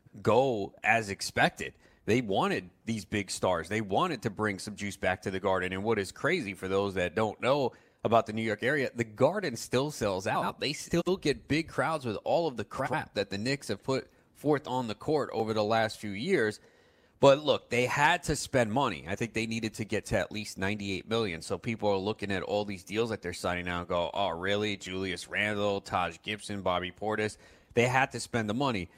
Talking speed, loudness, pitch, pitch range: 220 wpm, -30 LUFS, 105 Hz, 100-120 Hz